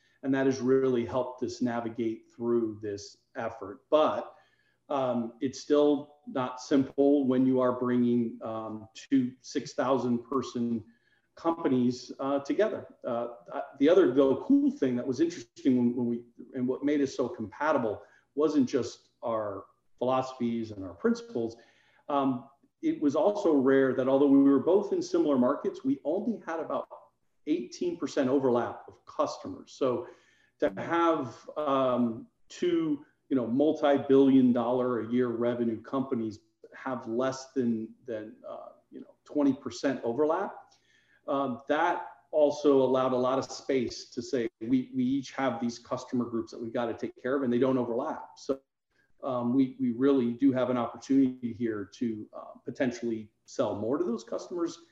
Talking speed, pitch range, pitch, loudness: 155 wpm, 120-145 Hz, 130 Hz, -29 LUFS